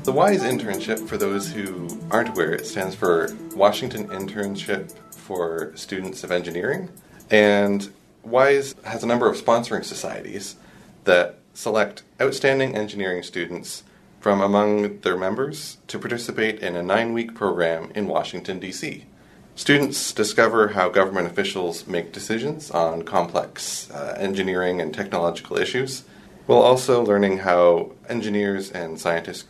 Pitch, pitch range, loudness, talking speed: 100 Hz, 90-115 Hz, -22 LUFS, 130 wpm